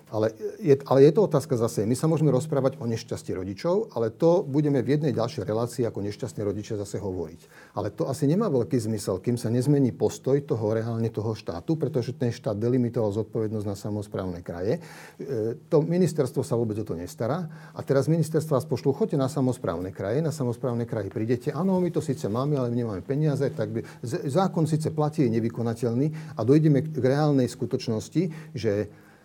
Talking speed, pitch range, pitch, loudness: 185 wpm, 115-150 Hz, 130 Hz, -26 LUFS